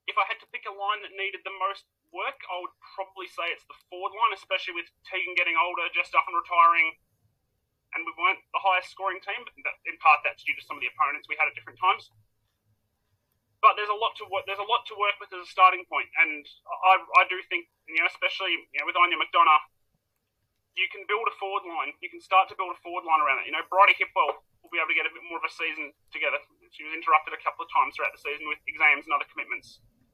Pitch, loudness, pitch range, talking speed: 180 Hz, -25 LUFS, 150-195 Hz, 255 wpm